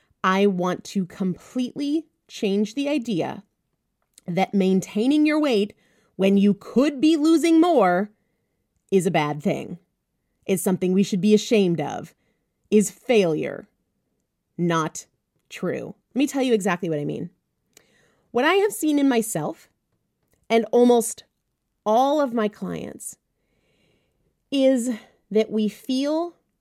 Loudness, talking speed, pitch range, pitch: -22 LUFS, 125 wpm, 190-265 Hz, 215 Hz